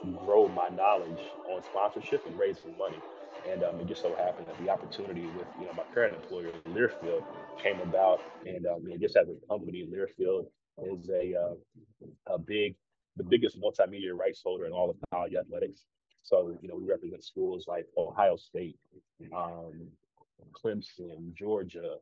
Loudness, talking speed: -32 LUFS, 165 wpm